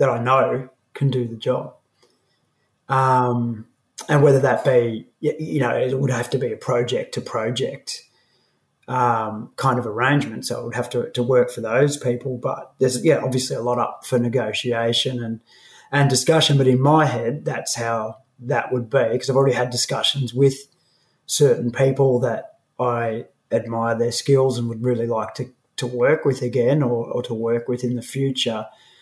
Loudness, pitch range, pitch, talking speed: -21 LUFS, 120-135 Hz, 125 Hz, 180 wpm